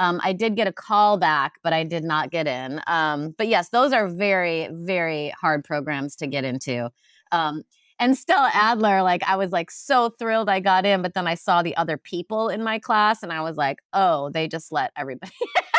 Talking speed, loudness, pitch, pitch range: 215 wpm, -22 LUFS, 175 Hz, 160-210 Hz